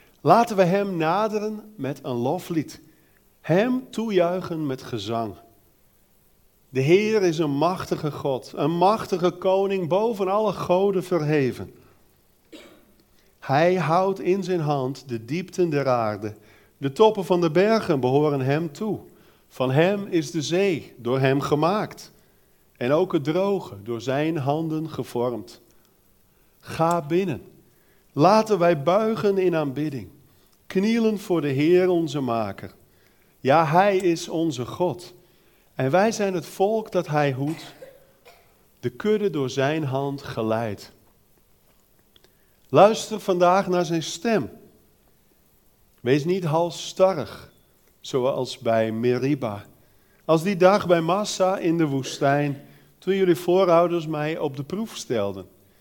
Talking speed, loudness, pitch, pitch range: 125 wpm, -23 LUFS, 165 Hz, 135-185 Hz